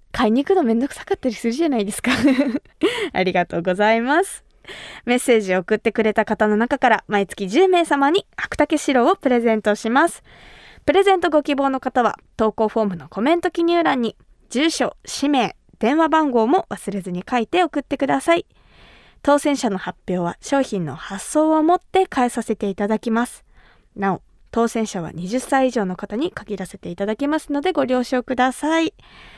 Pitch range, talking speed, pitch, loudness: 215-300 Hz, 355 characters per minute, 250 Hz, -20 LUFS